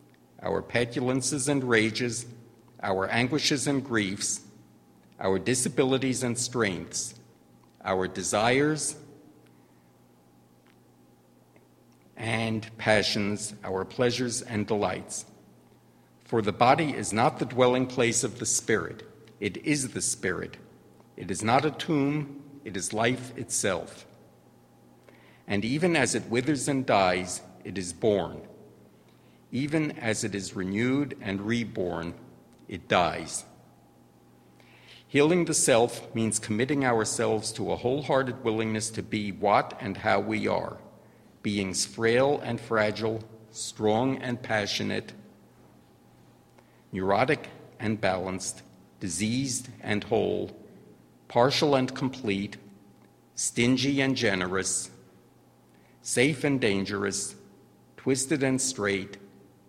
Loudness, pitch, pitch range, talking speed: -27 LUFS, 110 Hz, 95-130 Hz, 105 wpm